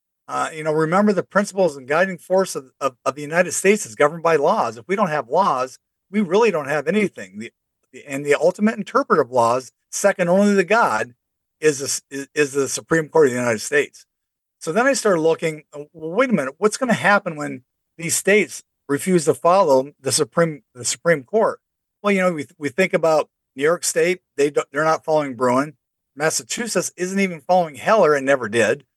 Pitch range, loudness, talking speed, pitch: 140-190 Hz, -19 LUFS, 210 wpm, 160 Hz